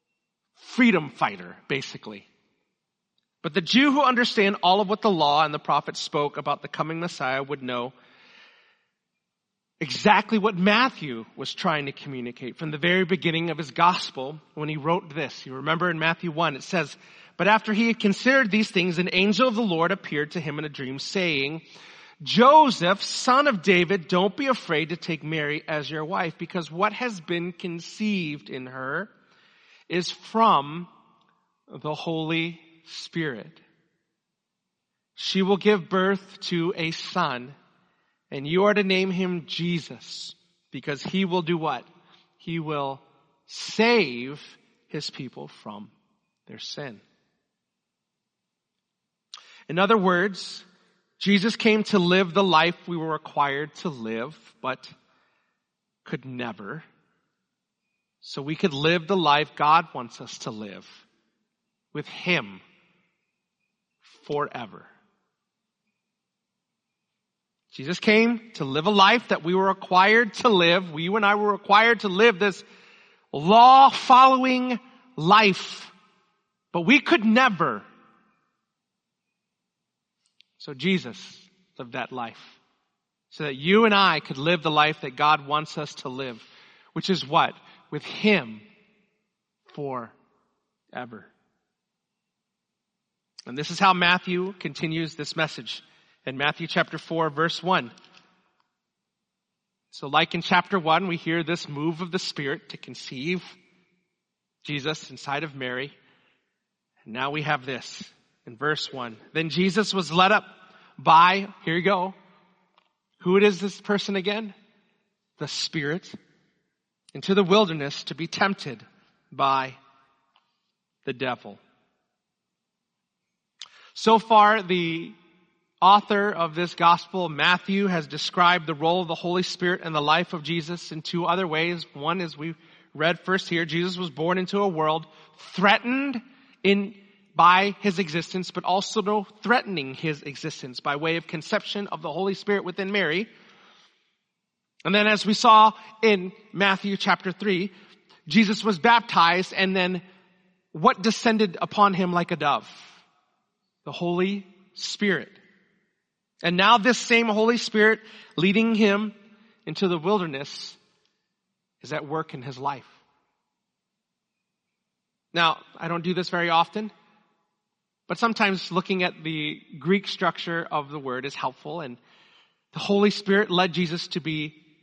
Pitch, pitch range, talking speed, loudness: 185 Hz, 160-205 Hz, 135 wpm, -23 LUFS